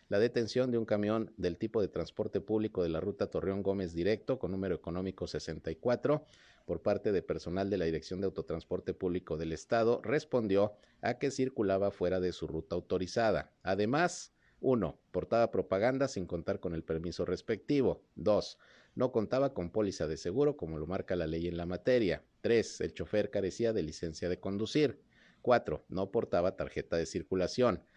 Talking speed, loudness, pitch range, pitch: 170 wpm, -34 LUFS, 90-115 Hz, 95 Hz